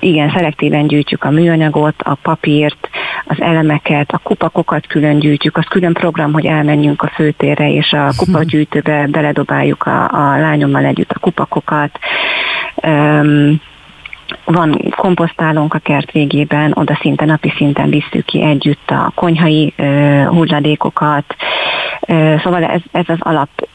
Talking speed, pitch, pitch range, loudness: 135 wpm, 155 Hz, 150-165 Hz, -12 LUFS